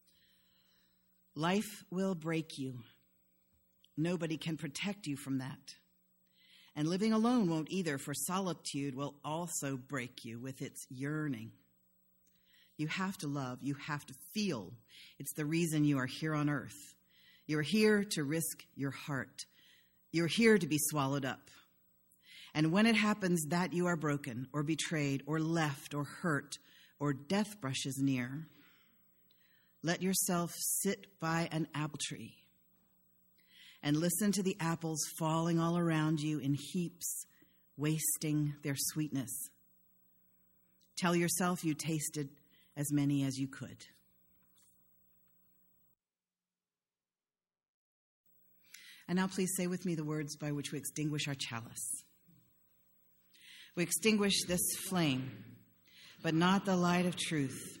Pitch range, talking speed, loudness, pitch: 135-170 Hz, 130 wpm, -35 LUFS, 150 Hz